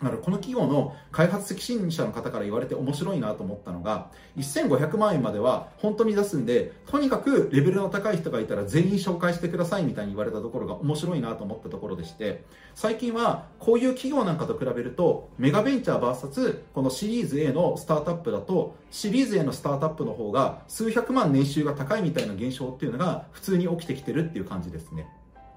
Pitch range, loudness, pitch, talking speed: 135-215 Hz, -26 LUFS, 170 Hz, 440 characters per minute